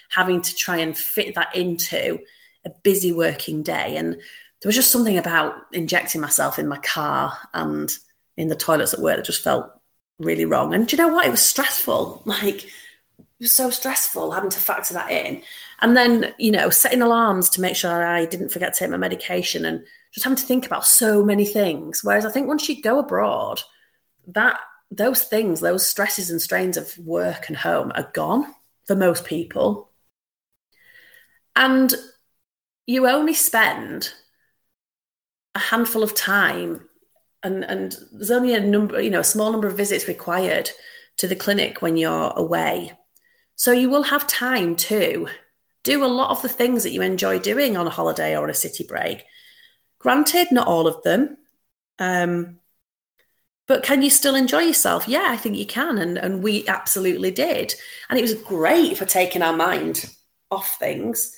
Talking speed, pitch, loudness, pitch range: 180 wpm, 215 Hz, -20 LUFS, 175-275 Hz